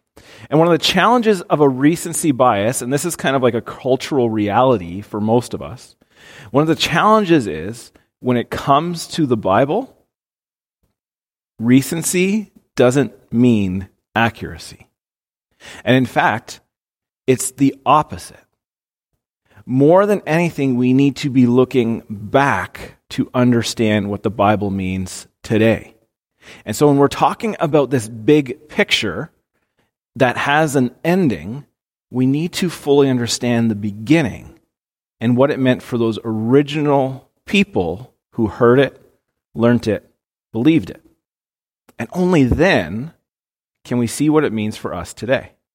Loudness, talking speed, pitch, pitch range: -17 LUFS, 140 wpm, 130 Hz, 115-150 Hz